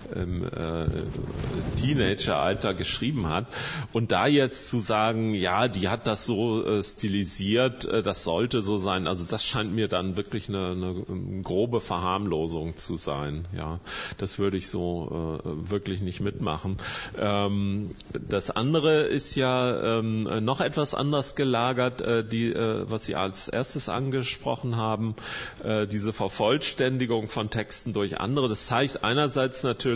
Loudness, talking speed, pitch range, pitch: -27 LUFS, 145 wpm, 95-120 Hz, 110 Hz